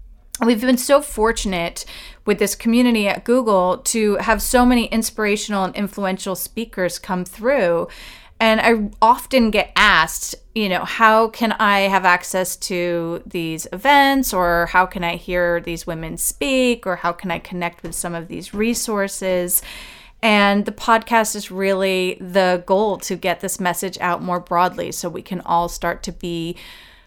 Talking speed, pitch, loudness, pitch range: 160 wpm, 195 Hz, -18 LUFS, 180-225 Hz